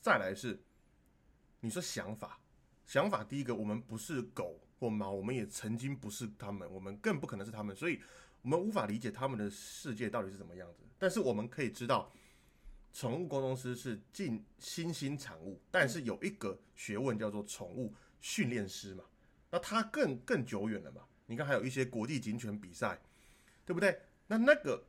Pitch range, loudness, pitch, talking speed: 105-135 Hz, -38 LUFS, 115 Hz, 280 characters per minute